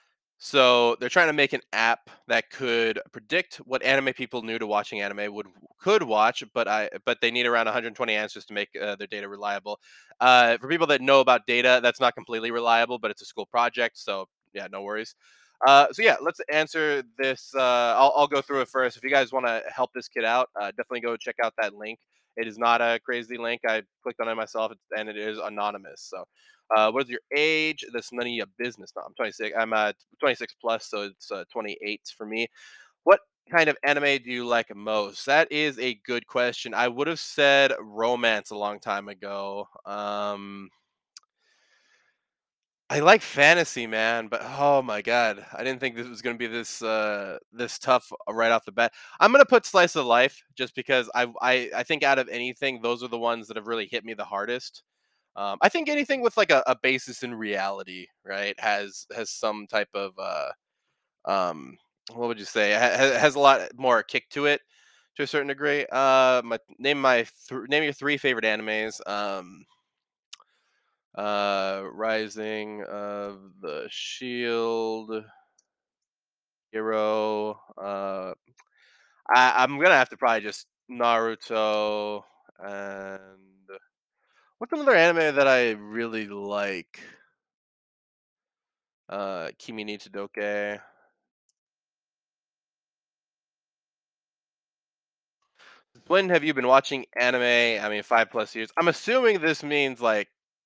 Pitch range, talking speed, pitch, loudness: 105-130 Hz, 170 wpm, 115 Hz, -24 LUFS